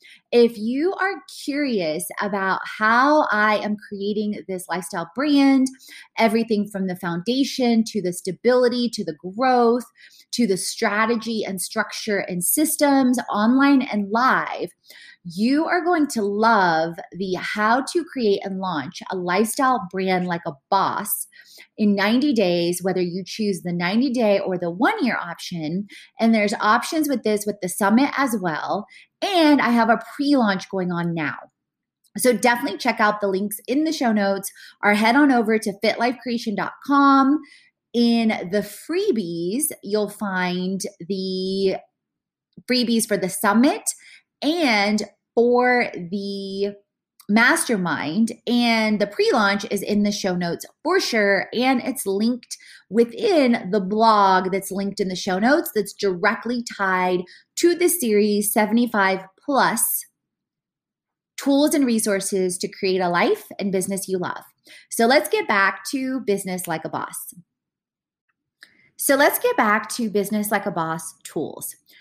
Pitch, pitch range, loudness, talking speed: 210 Hz, 195-250 Hz, -21 LUFS, 145 wpm